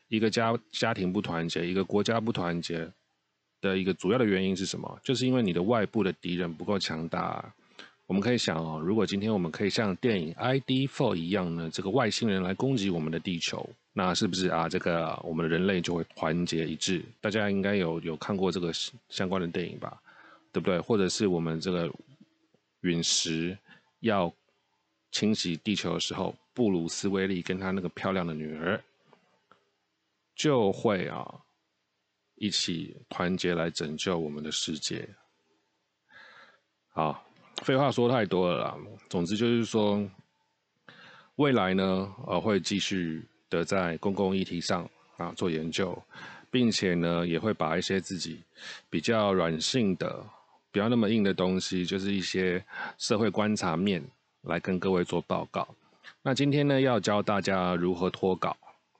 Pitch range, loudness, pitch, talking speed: 85-105 Hz, -29 LUFS, 95 Hz, 250 characters per minute